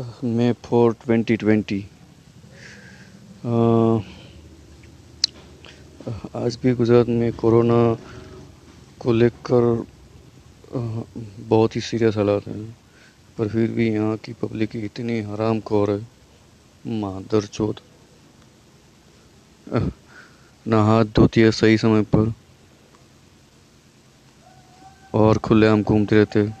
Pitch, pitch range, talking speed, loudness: 110 Hz, 105-115 Hz, 85 wpm, -20 LUFS